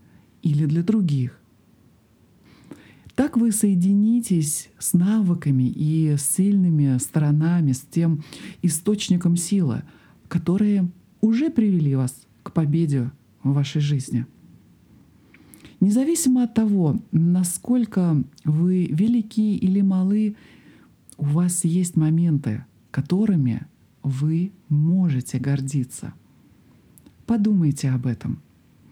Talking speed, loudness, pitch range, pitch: 90 wpm, -22 LUFS, 140-195 Hz, 170 Hz